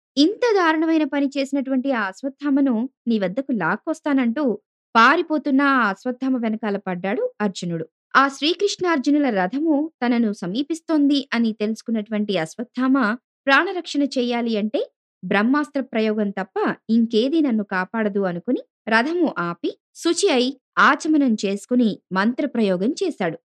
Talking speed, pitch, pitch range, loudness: 100 wpm, 255 Hz, 215-290 Hz, -21 LUFS